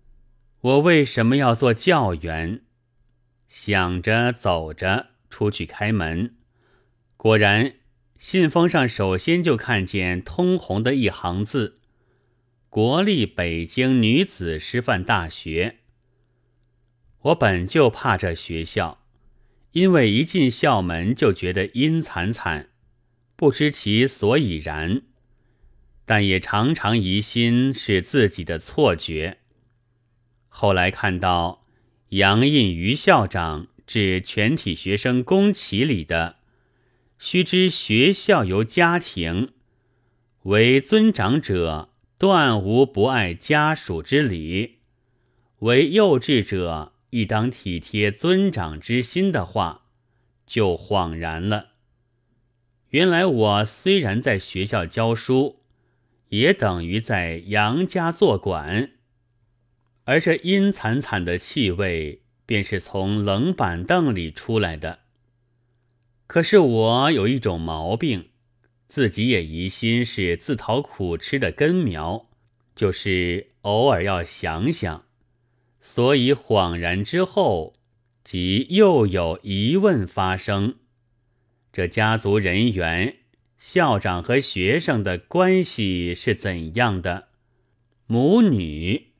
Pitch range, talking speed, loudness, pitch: 95-125 Hz, 155 characters per minute, -21 LUFS, 115 Hz